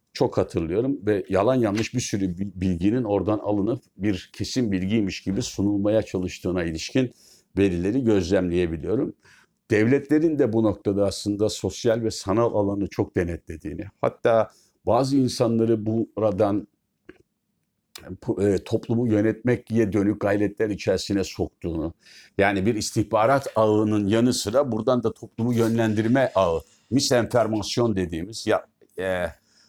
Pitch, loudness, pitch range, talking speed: 105 Hz, -24 LUFS, 100-115 Hz, 120 wpm